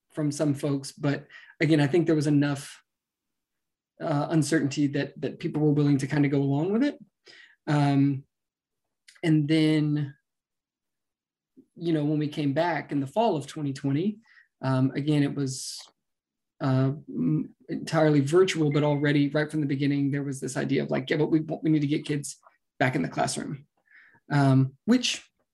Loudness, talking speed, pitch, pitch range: -26 LUFS, 165 wpm, 145 Hz, 140-155 Hz